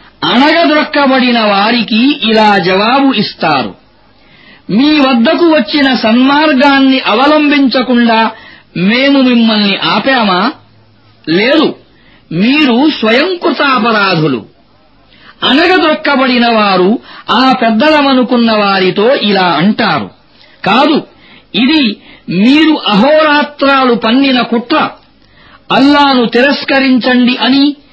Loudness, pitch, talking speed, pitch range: -8 LUFS, 260 Hz, 70 wpm, 225-285 Hz